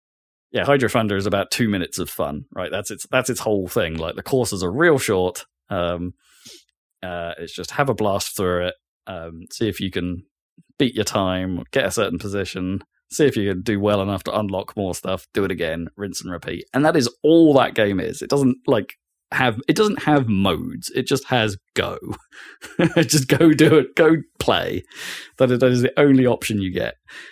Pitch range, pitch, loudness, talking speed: 95-135 Hz, 105 Hz, -20 LUFS, 200 wpm